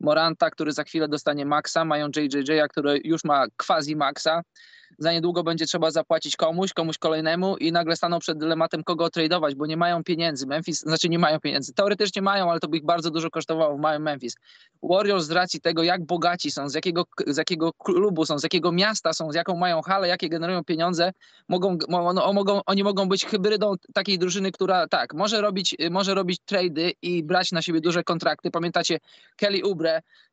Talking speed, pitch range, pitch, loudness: 195 wpm, 160-185 Hz, 170 Hz, -24 LUFS